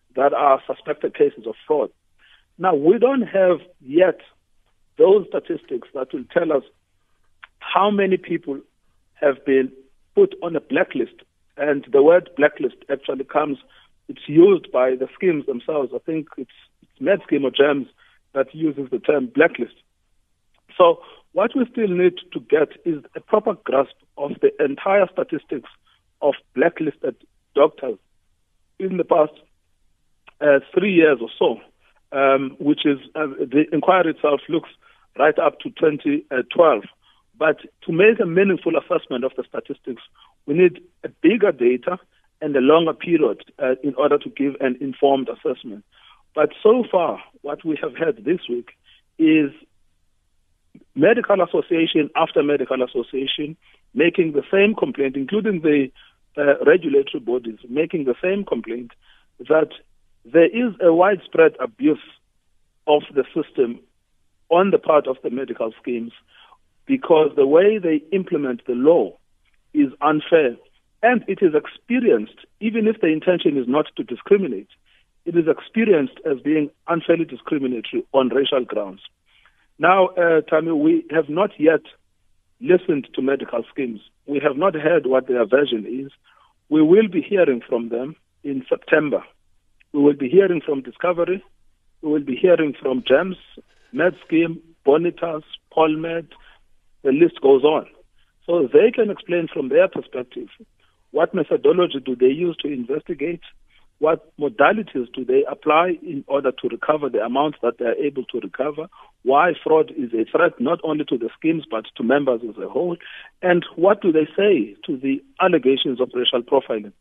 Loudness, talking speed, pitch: -19 LUFS, 150 wpm, 170 Hz